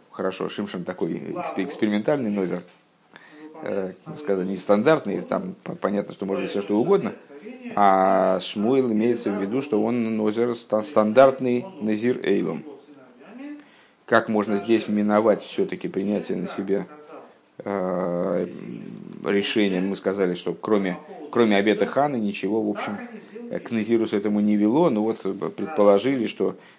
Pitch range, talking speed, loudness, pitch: 100-130 Hz, 120 wpm, -23 LUFS, 105 Hz